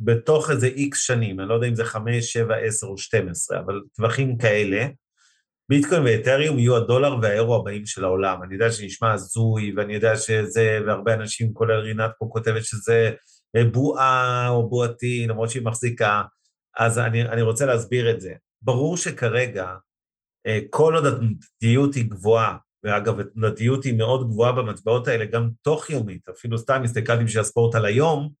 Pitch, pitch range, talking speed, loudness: 115 Hz, 110-125 Hz, 165 wpm, -22 LUFS